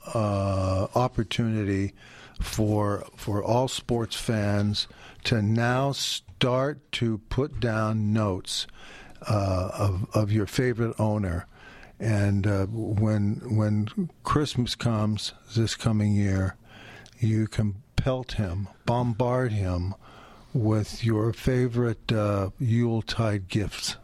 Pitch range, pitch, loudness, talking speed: 105-120 Hz, 110 Hz, -27 LUFS, 105 wpm